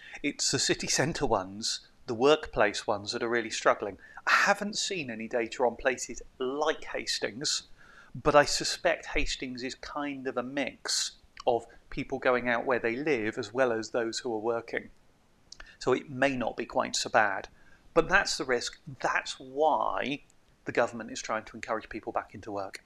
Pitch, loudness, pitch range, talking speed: 120 Hz, -30 LUFS, 115-145 Hz, 180 wpm